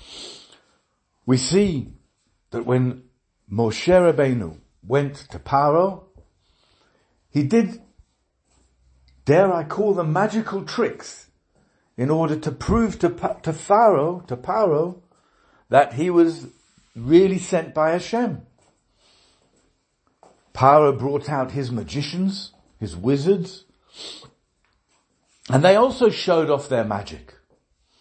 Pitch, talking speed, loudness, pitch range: 145 Hz, 100 wpm, -20 LUFS, 120-180 Hz